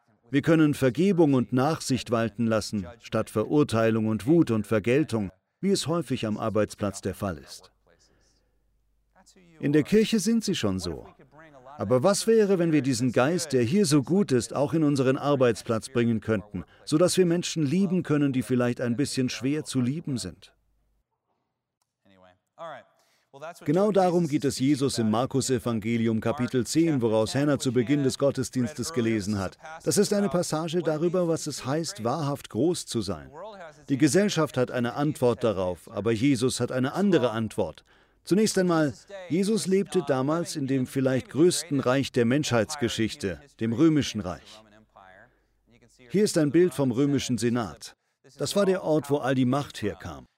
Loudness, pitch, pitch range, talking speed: -25 LUFS, 130 Hz, 115-160 Hz, 160 wpm